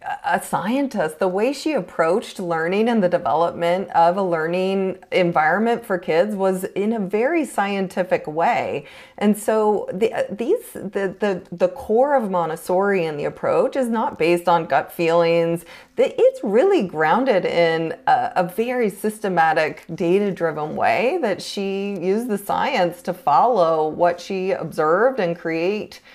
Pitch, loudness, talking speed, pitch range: 190 Hz, -20 LUFS, 145 wpm, 170-220 Hz